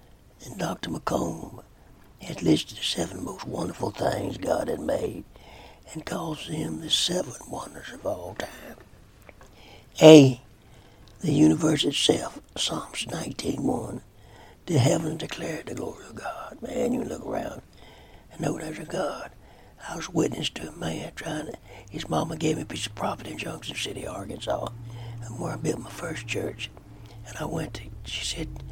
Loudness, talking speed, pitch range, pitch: -26 LUFS, 160 wpm, 100-130 Hz, 115 Hz